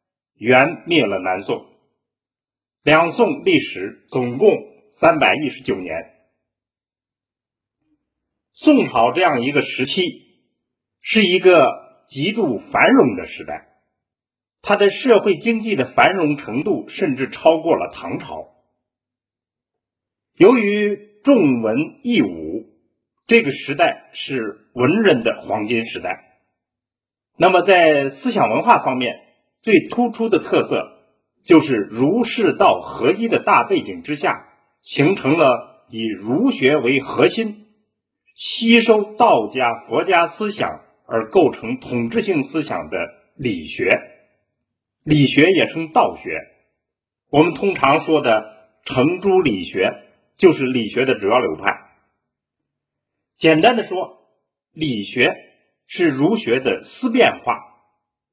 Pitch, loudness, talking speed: 195 Hz, -17 LUFS, 170 characters per minute